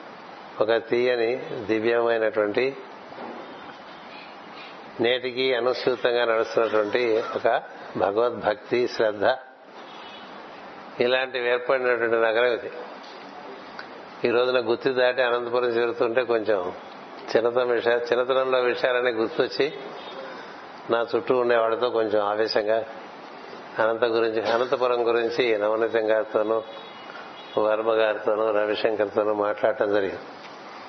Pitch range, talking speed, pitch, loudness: 110-125 Hz, 80 wpm, 115 Hz, -24 LUFS